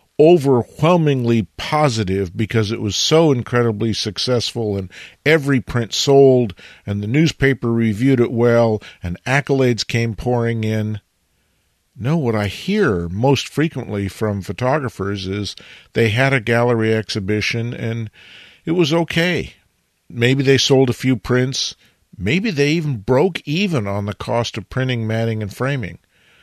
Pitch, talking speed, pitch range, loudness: 120 Hz, 135 wpm, 110-135 Hz, -18 LUFS